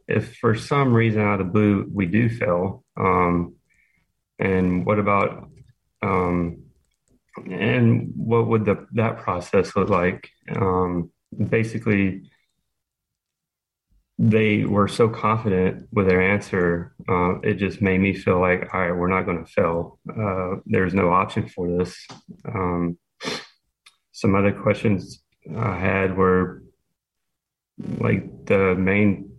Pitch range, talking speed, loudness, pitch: 90-110 Hz, 130 wpm, -22 LUFS, 95 Hz